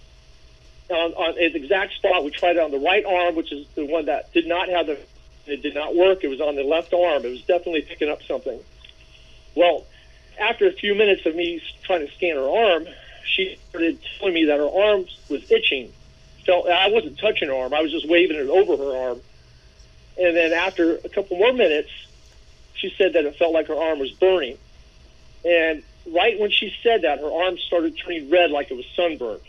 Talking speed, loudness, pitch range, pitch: 210 wpm, -21 LUFS, 145-185 Hz, 170 Hz